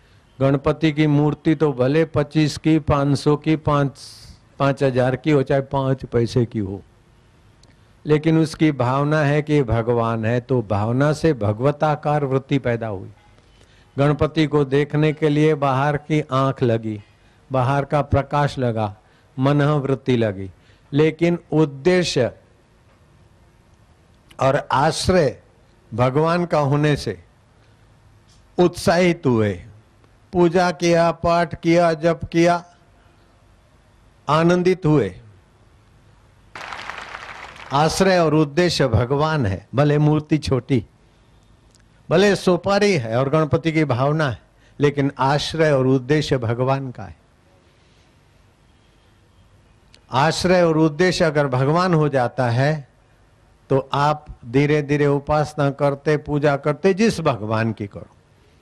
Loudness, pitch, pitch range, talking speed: -19 LUFS, 135 Hz, 115-155 Hz, 115 wpm